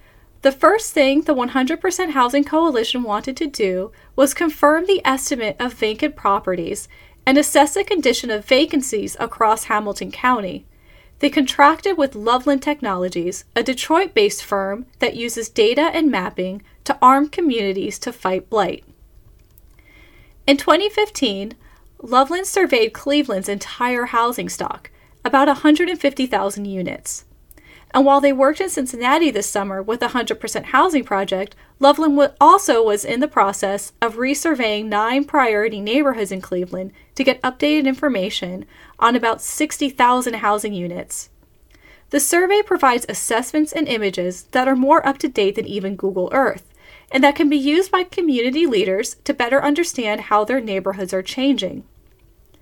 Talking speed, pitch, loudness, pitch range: 140 wpm, 260 Hz, -18 LUFS, 210-295 Hz